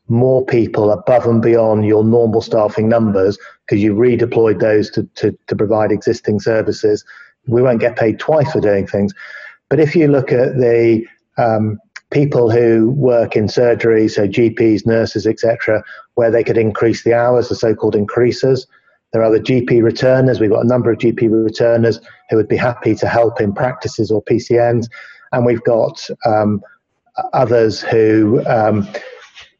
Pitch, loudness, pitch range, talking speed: 115 Hz, -14 LUFS, 110-120 Hz, 165 wpm